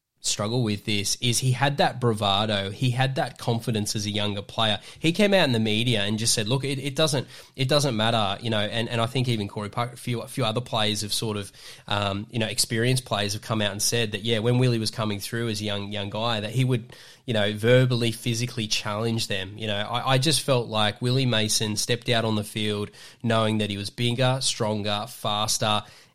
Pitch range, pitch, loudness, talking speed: 105-125 Hz, 115 Hz, -25 LUFS, 235 wpm